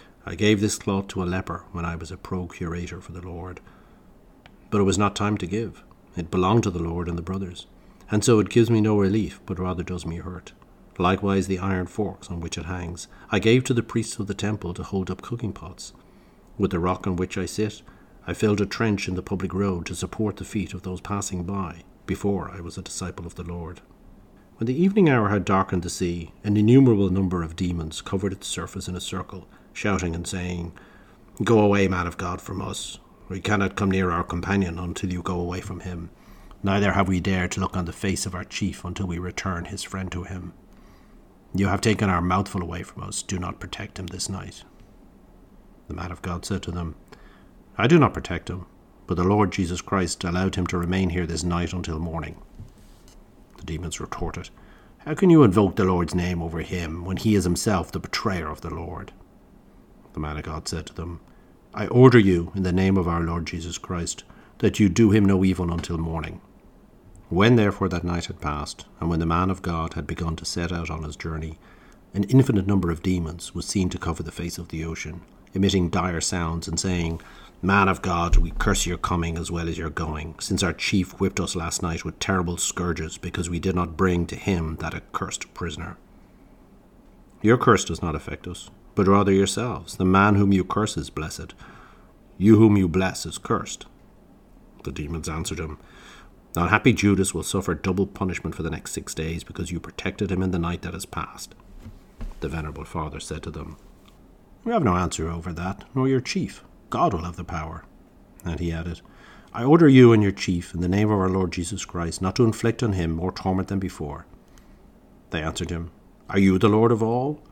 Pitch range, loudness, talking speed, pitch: 85-100 Hz, -24 LUFS, 210 wpm, 90 Hz